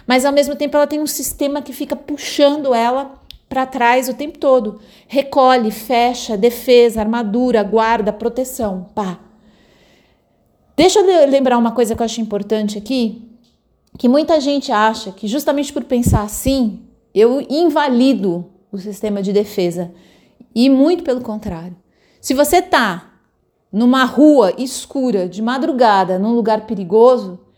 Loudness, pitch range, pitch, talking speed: -15 LUFS, 215-275 Hz, 240 Hz, 140 wpm